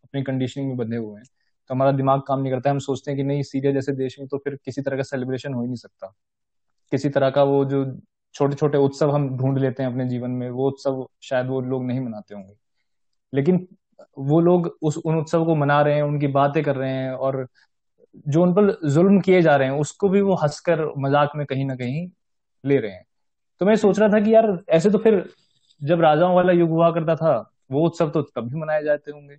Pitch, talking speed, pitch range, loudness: 140 Hz, 235 wpm, 130-160 Hz, -21 LUFS